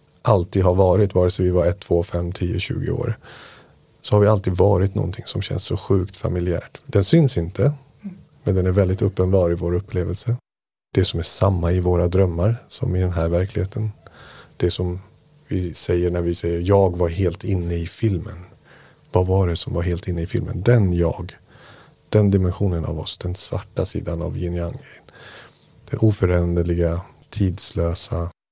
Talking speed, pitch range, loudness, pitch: 180 wpm, 85-110 Hz, -21 LUFS, 95 Hz